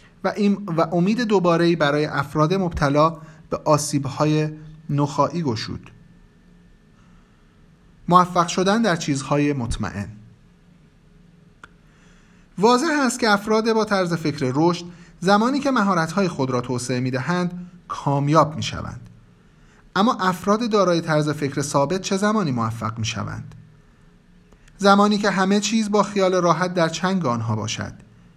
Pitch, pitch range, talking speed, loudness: 170 Hz, 145-195 Hz, 120 wpm, -20 LUFS